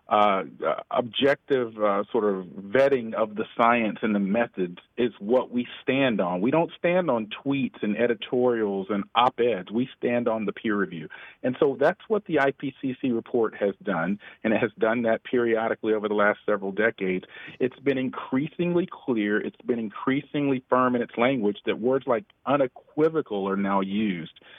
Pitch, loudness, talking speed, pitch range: 120 Hz, -25 LUFS, 175 wpm, 105-135 Hz